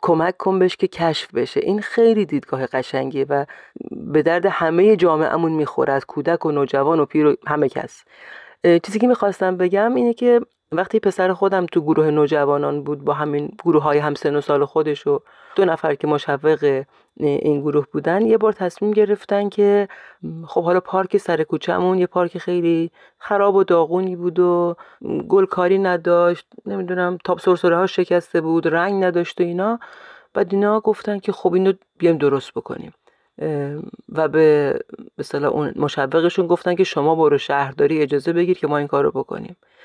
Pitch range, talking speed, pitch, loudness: 150-195 Hz, 165 wpm, 175 Hz, -19 LUFS